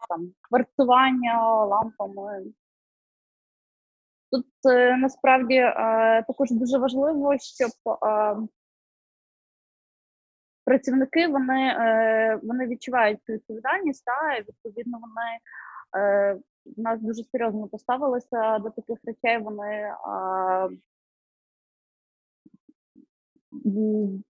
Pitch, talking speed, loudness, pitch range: 230 Hz, 80 wpm, -24 LUFS, 215-260 Hz